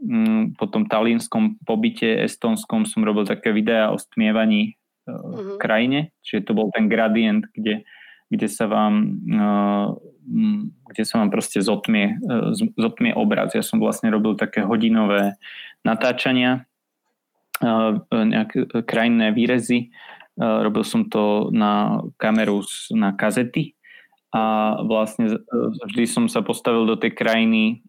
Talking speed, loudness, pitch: 120 wpm, -20 LUFS, 125 Hz